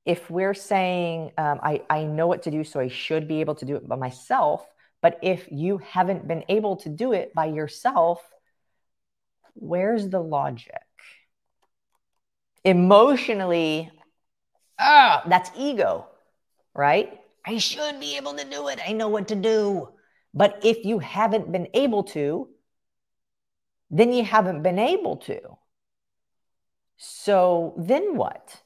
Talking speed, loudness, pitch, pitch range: 140 wpm, -23 LUFS, 180 Hz, 155-215 Hz